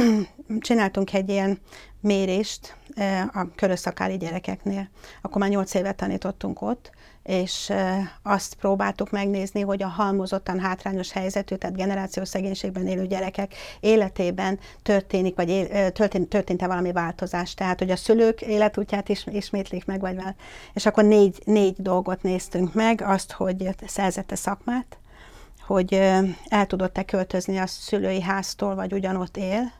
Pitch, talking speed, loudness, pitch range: 195 Hz, 135 wpm, -24 LUFS, 185-200 Hz